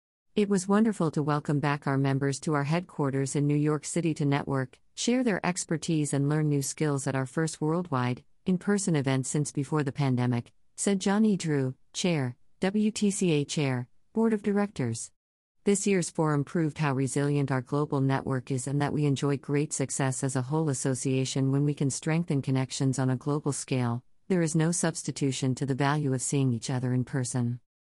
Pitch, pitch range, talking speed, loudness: 145 Hz, 135-160 Hz, 185 wpm, -28 LUFS